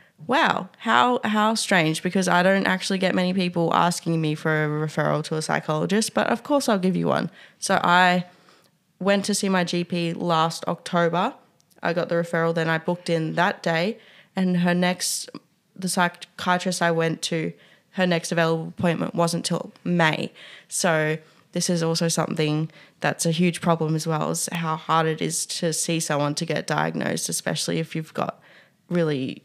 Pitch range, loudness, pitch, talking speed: 160-185 Hz, -23 LUFS, 170 Hz, 175 wpm